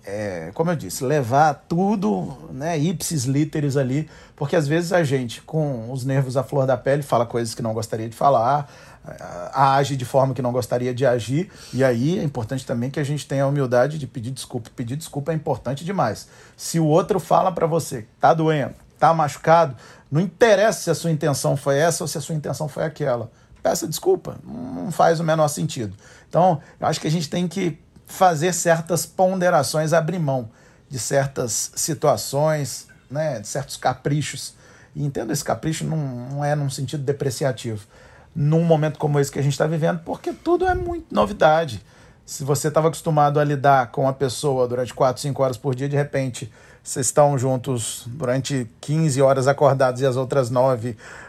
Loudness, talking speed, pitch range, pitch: -21 LUFS, 185 wpm, 130-160 Hz, 145 Hz